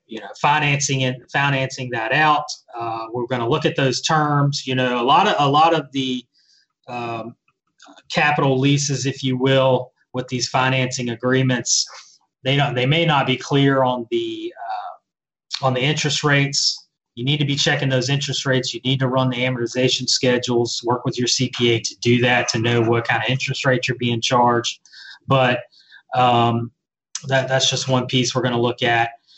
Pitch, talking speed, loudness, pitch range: 130 Hz, 190 wpm, -19 LUFS, 125-140 Hz